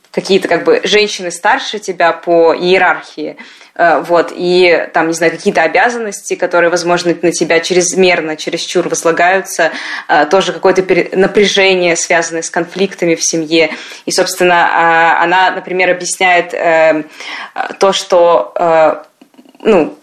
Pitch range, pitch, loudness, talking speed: 165-185 Hz, 175 Hz, -11 LUFS, 115 wpm